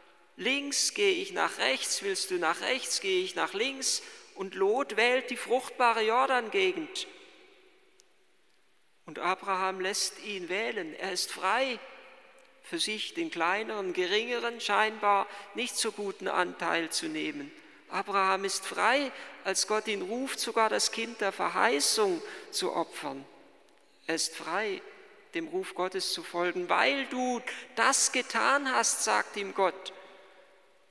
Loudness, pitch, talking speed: -29 LUFS, 255 Hz, 135 wpm